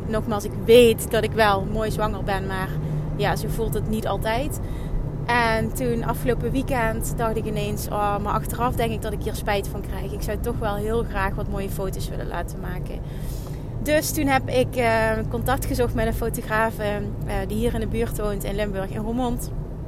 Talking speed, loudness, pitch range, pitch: 195 wpm, -24 LUFS, 115-170 Hz, 140 Hz